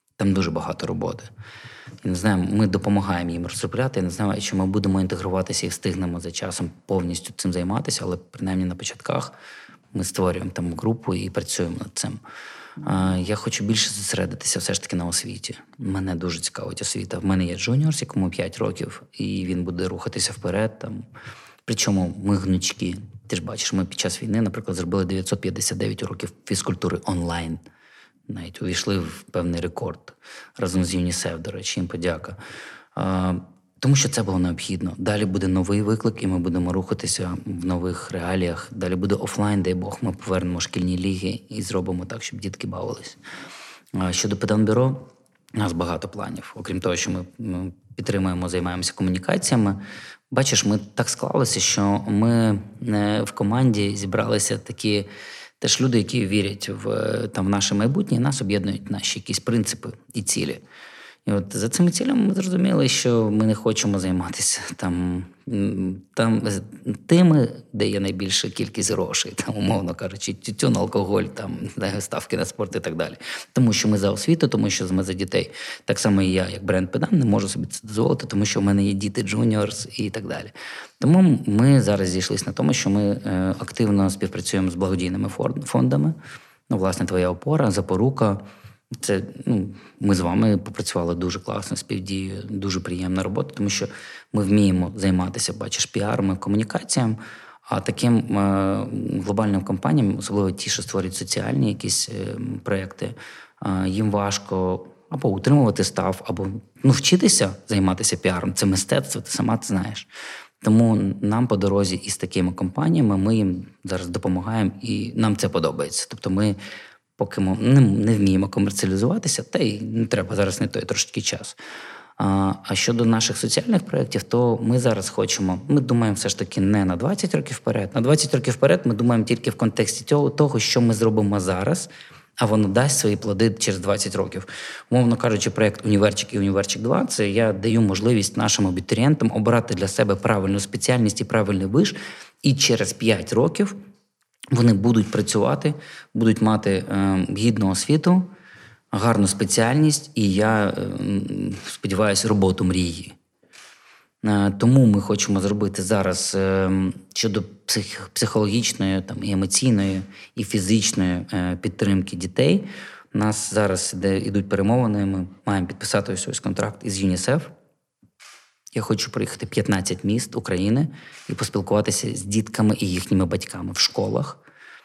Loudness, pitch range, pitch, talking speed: -22 LUFS, 95-115 Hz, 100 Hz, 155 wpm